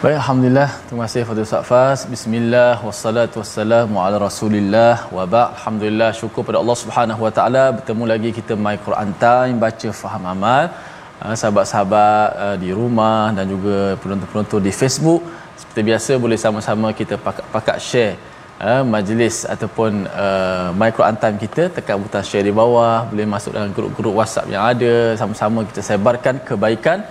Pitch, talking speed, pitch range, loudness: 110 Hz, 145 wpm, 105-120 Hz, -17 LUFS